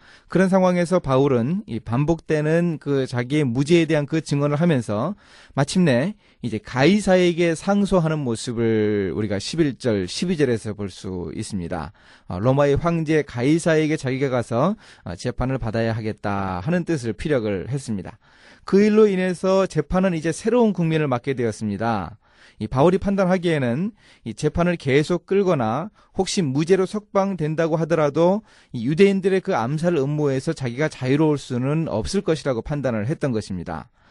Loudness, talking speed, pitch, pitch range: -21 LUFS, 330 characters per minute, 150 Hz, 115-175 Hz